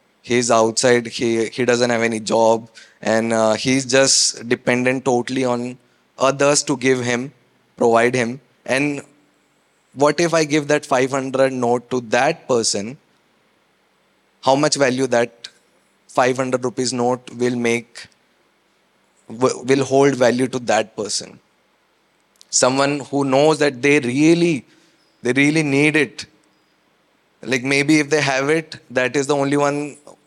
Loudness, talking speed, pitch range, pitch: -18 LUFS, 135 wpm, 120-140 Hz, 130 Hz